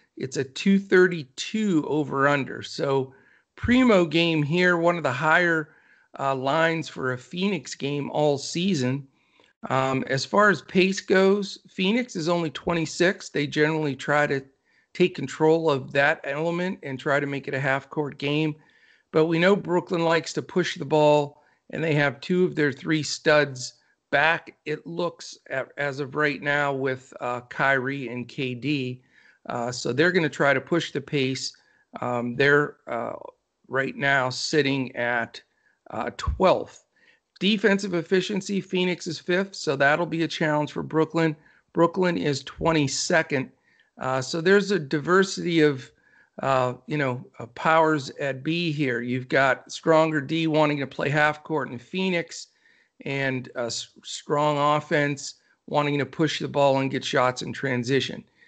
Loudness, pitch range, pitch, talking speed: -24 LUFS, 135-170 Hz, 150 Hz, 155 wpm